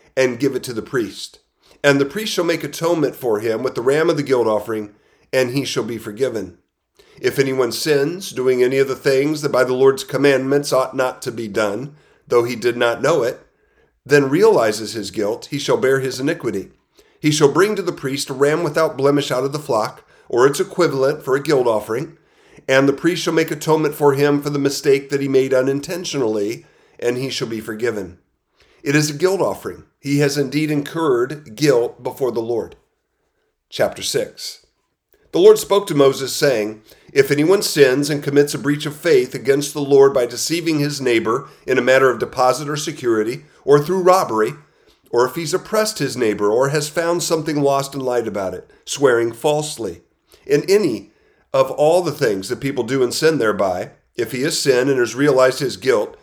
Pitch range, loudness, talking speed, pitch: 130-170 Hz, -18 LUFS, 195 wpm, 145 Hz